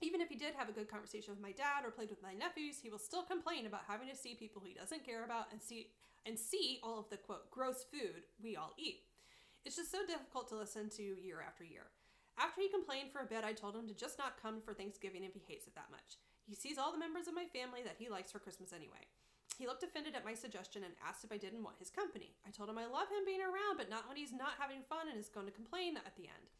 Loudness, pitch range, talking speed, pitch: -46 LUFS, 210-315 Hz, 280 wpm, 240 Hz